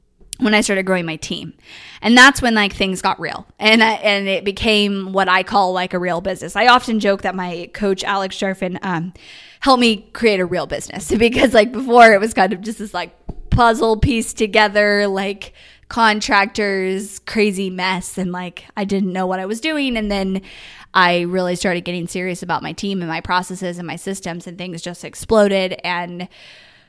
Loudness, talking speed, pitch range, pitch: -17 LUFS, 195 wpm, 185-215 Hz, 195 Hz